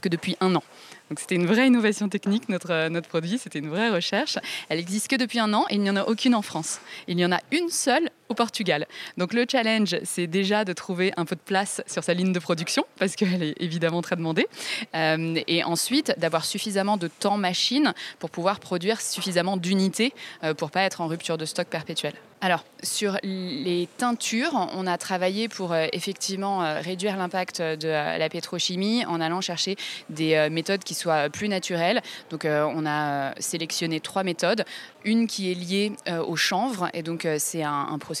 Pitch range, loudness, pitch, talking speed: 165-210 Hz, -25 LUFS, 185 Hz, 190 wpm